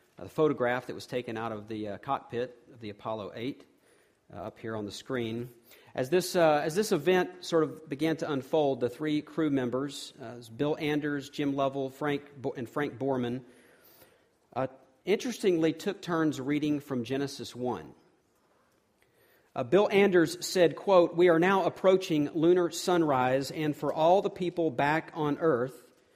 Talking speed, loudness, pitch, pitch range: 165 wpm, -29 LUFS, 145 Hz, 125-165 Hz